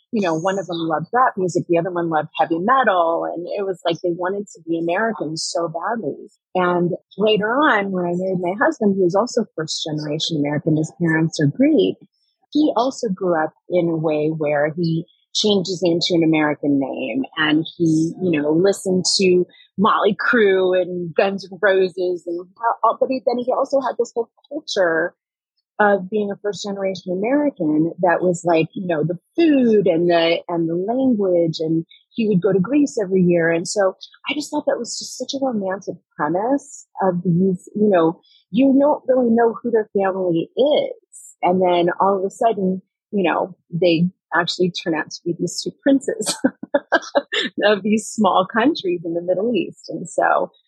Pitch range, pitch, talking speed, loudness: 170-230 Hz, 185 Hz, 185 wpm, -19 LUFS